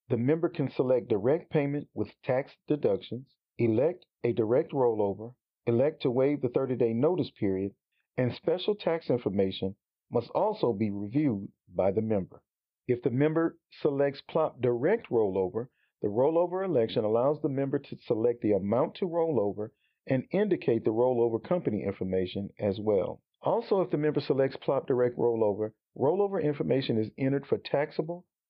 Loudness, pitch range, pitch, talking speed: -29 LUFS, 110-150 Hz, 125 Hz, 155 wpm